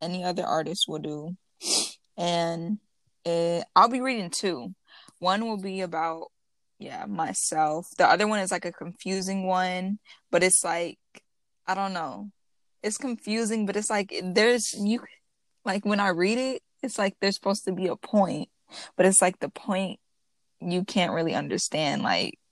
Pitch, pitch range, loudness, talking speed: 190 Hz, 175-210 Hz, -26 LUFS, 165 wpm